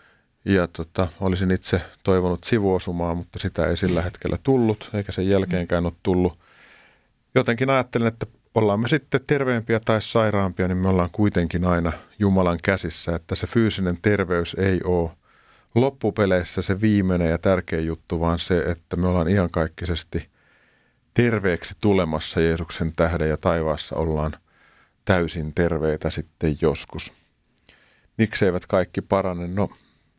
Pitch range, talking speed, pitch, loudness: 85-105 Hz, 135 wpm, 90 Hz, -23 LUFS